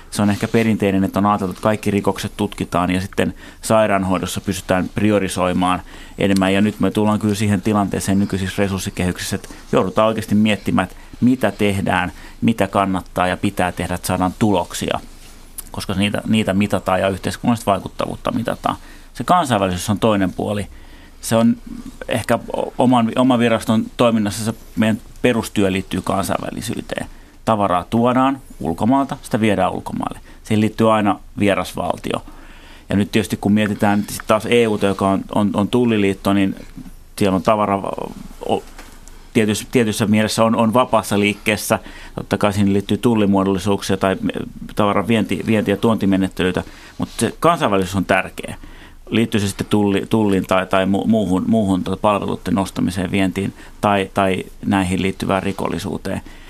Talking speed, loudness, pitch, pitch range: 140 wpm, -18 LUFS, 100 Hz, 95-110 Hz